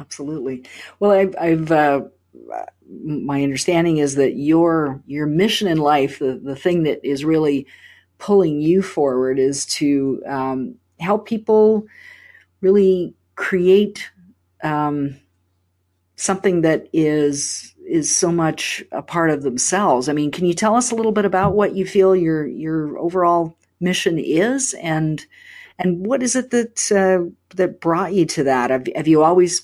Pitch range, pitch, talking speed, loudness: 145-195 Hz, 165 Hz, 150 wpm, -18 LUFS